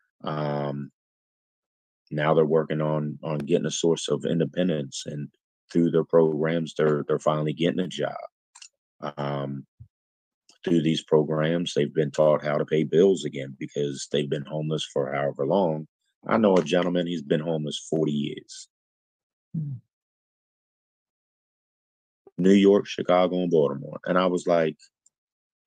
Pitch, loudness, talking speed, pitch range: 75 Hz, -25 LUFS, 135 wpm, 75-85 Hz